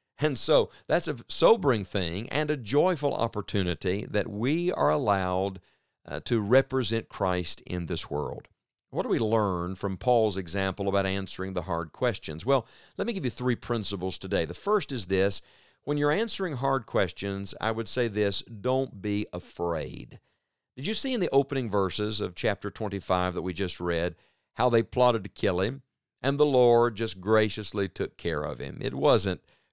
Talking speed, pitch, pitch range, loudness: 180 wpm, 105 Hz, 95-130 Hz, -28 LUFS